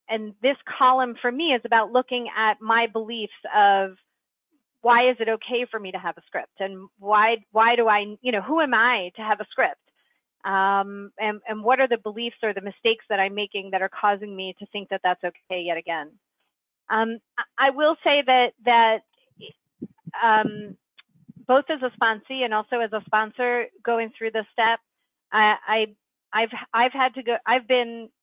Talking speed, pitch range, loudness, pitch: 190 wpm, 205-245 Hz, -23 LUFS, 225 Hz